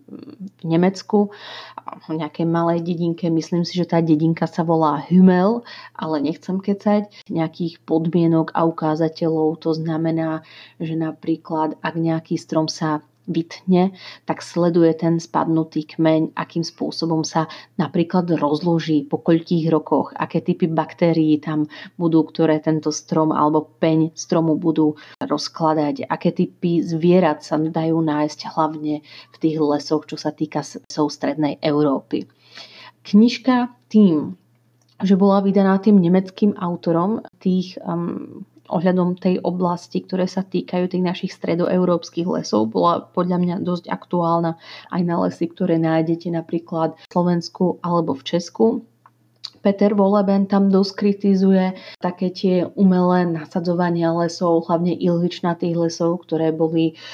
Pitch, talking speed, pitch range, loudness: 170 Hz, 130 wpm, 160-180 Hz, -20 LUFS